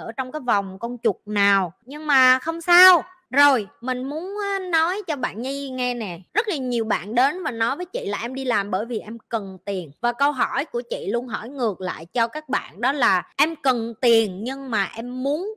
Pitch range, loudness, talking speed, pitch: 225-310 Hz, -22 LUFS, 230 wpm, 255 Hz